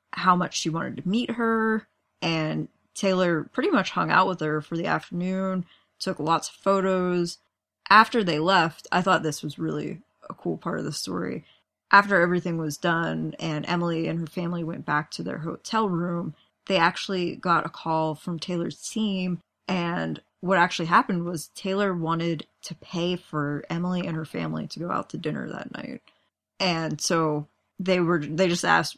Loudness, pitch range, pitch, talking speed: -25 LUFS, 160-185 Hz, 175 Hz, 180 wpm